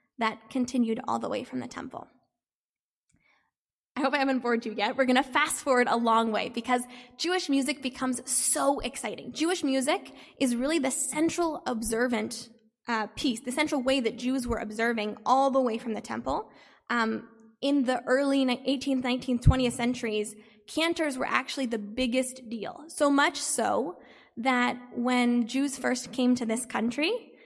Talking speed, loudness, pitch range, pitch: 165 wpm, -28 LUFS, 235-275 Hz, 255 Hz